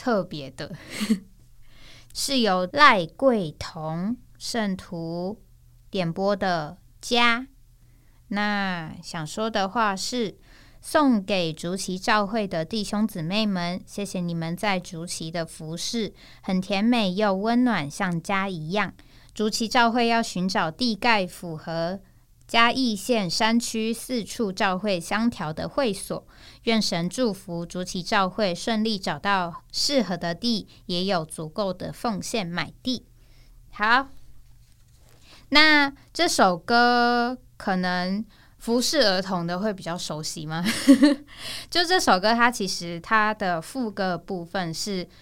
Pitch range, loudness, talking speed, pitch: 170-230 Hz, -24 LUFS, 180 characters per minute, 195 Hz